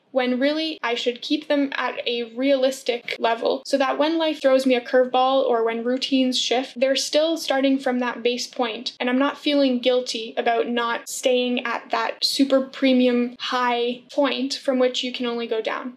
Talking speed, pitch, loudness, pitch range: 190 wpm, 255 Hz, -22 LUFS, 245-270 Hz